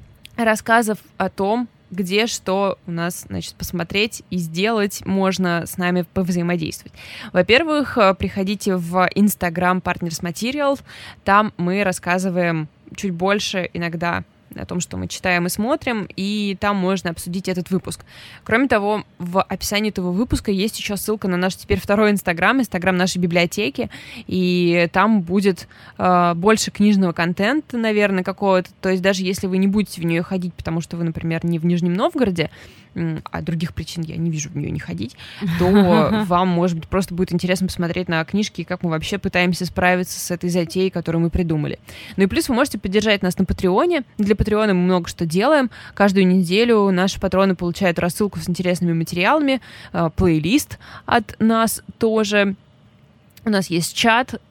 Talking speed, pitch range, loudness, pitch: 160 wpm, 175-205 Hz, -19 LUFS, 185 Hz